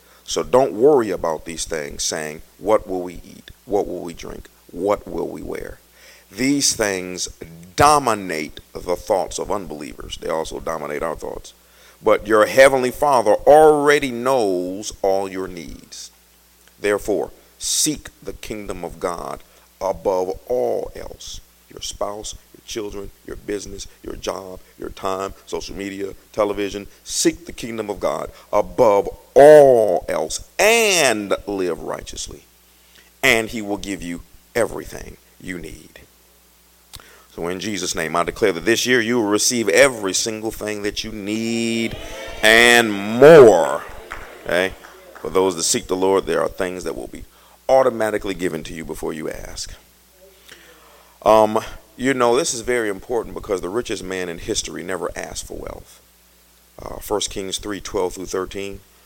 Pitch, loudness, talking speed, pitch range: 95 Hz, -18 LUFS, 150 wpm, 85-110 Hz